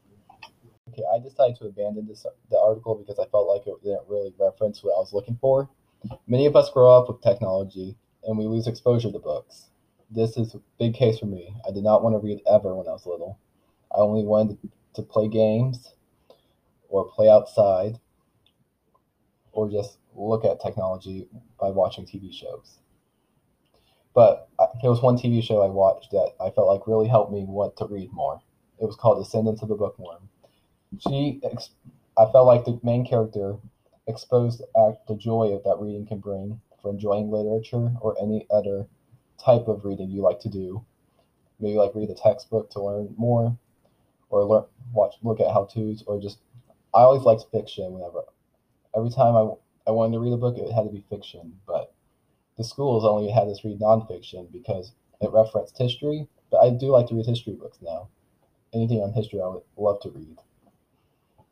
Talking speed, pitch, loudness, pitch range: 185 wpm, 110 Hz, -23 LUFS, 105-120 Hz